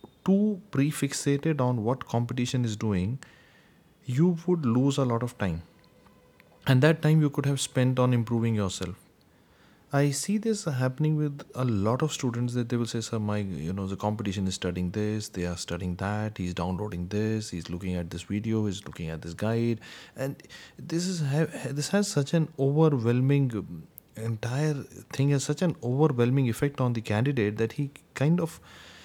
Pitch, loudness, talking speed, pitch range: 125 Hz, -28 LUFS, 175 wpm, 105-145 Hz